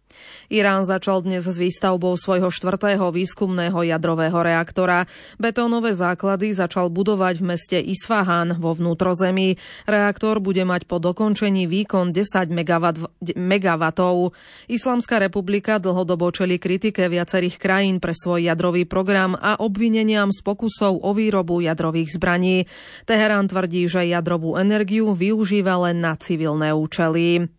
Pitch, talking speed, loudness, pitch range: 185 Hz, 120 wpm, -20 LUFS, 175-200 Hz